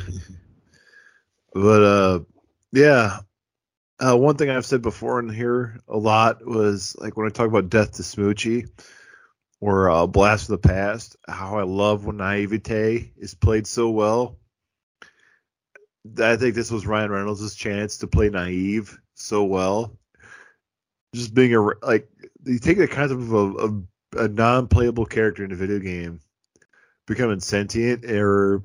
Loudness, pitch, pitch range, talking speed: -21 LUFS, 105 Hz, 100-115 Hz, 150 wpm